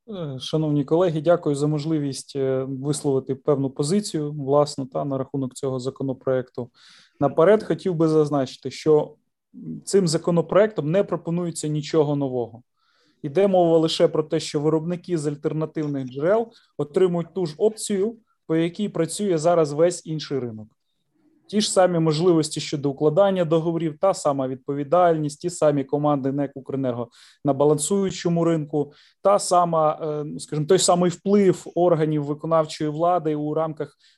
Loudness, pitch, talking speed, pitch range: -22 LUFS, 155 Hz, 130 wpm, 145-175 Hz